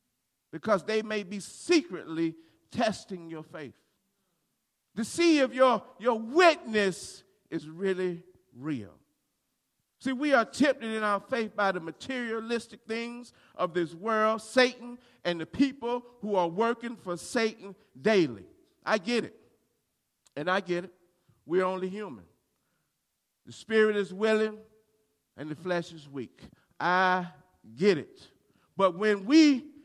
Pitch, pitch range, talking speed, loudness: 210 Hz, 175-235 Hz, 135 wpm, -28 LUFS